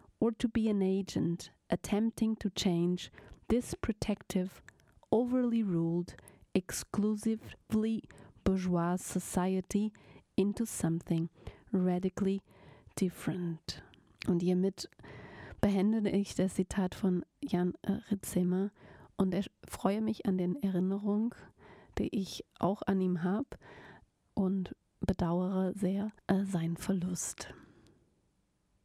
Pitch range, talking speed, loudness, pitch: 180-210 Hz, 100 wpm, -34 LUFS, 190 Hz